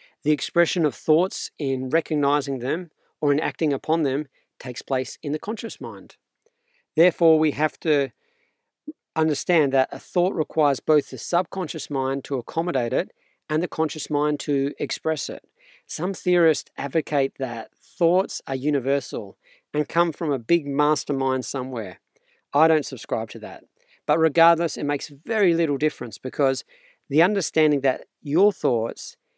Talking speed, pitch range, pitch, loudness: 150 wpm, 140-170 Hz, 155 Hz, -23 LUFS